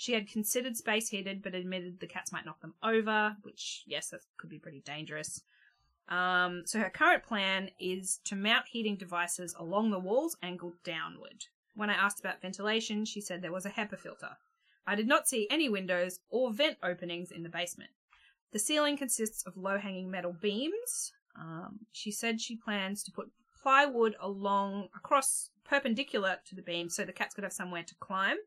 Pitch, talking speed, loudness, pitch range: 200 Hz, 190 wpm, -33 LUFS, 180-225 Hz